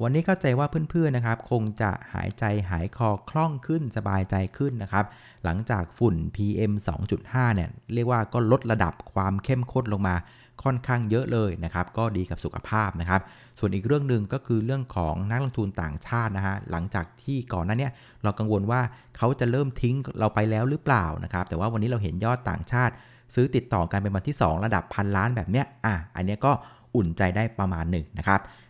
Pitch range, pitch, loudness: 95-125 Hz, 110 Hz, -27 LUFS